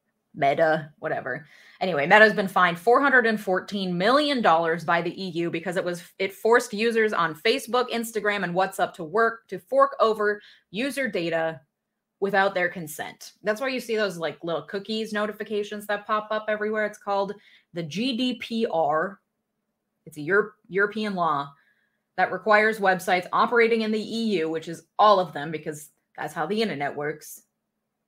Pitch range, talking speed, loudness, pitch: 175-220 Hz, 155 wpm, -24 LUFS, 205 Hz